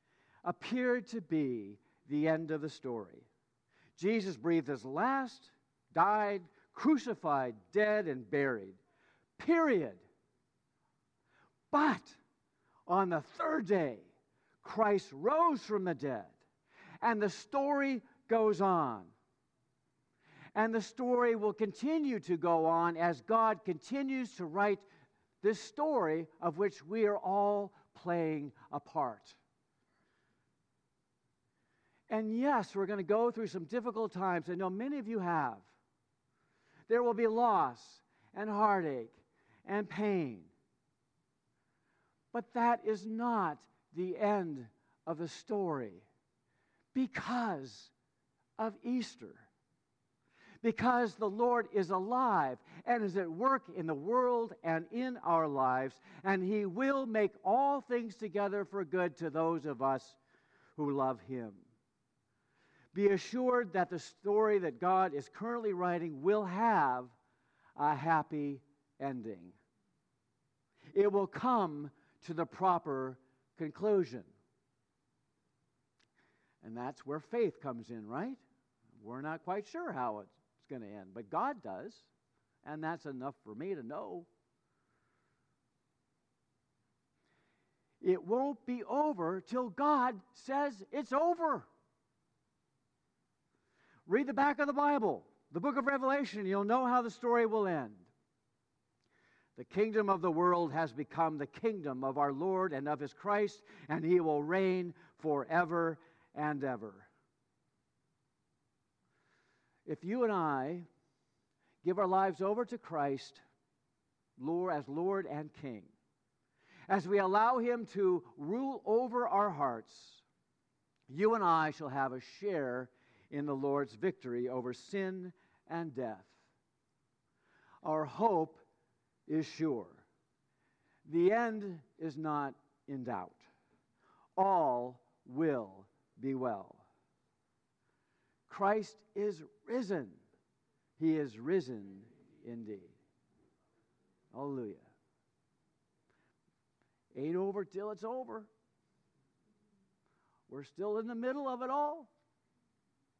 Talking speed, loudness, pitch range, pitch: 115 wpm, -35 LUFS, 140-220 Hz, 175 Hz